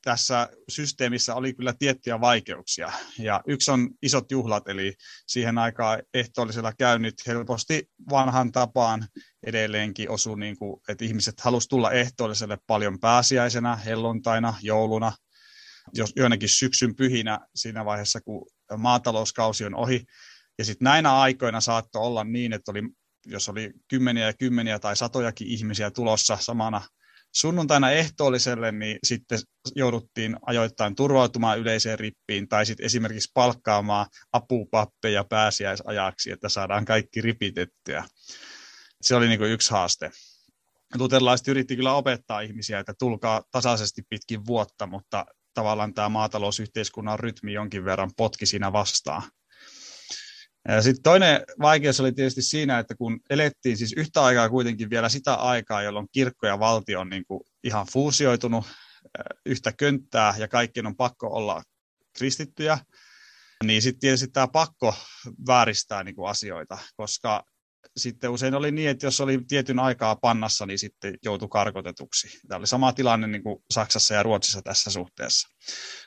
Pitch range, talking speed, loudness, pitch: 105-125 Hz, 135 wpm, -24 LUFS, 115 Hz